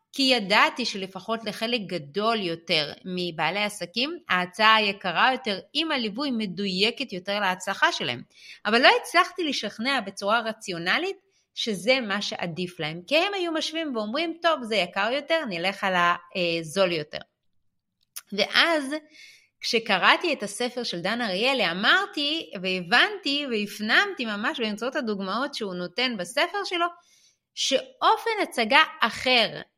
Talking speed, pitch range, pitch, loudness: 120 wpm, 195-305 Hz, 230 Hz, -24 LUFS